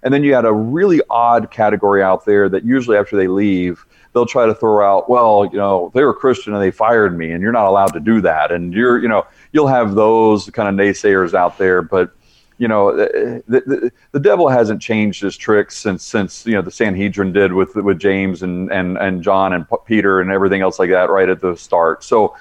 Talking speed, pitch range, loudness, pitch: 230 wpm, 95-110 Hz, -14 LUFS, 100 Hz